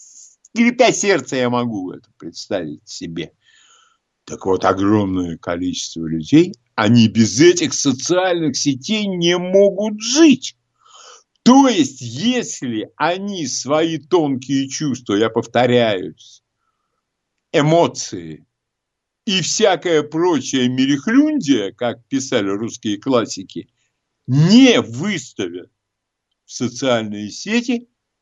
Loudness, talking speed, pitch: -17 LUFS, 90 wpm, 160 Hz